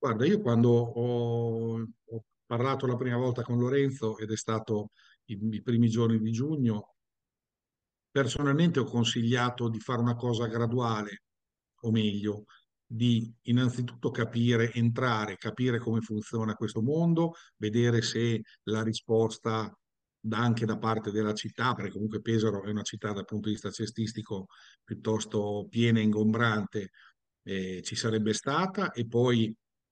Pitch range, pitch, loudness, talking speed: 110-120 Hz, 115 Hz, -30 LUFS, 140 wpm